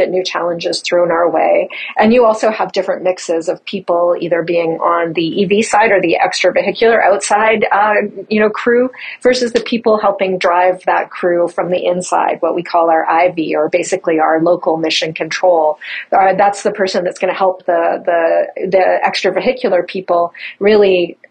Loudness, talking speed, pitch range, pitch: -13 LUFS, 175 wpm, 170-200 Hz, 185 Hz